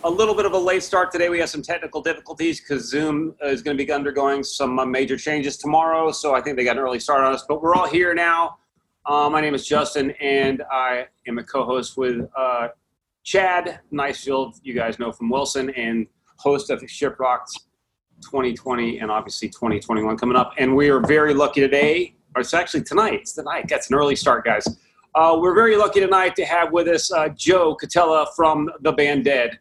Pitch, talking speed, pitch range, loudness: 145 Hz, 210 wpm, 130-165 Hz, -20 LUFS